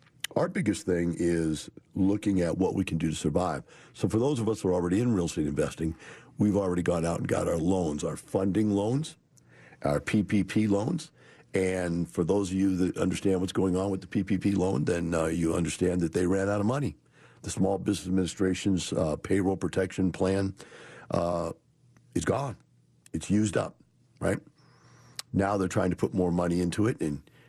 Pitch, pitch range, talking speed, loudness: 95 Hz, 85-100 Hz, 190 wpm, -29 LUFS